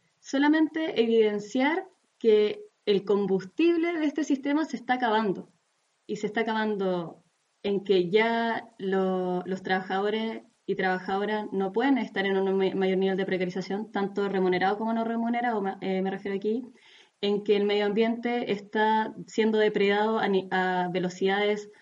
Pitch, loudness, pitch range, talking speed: 205 Hz, -27 LUFS, 190-230 Hz, 145 wpm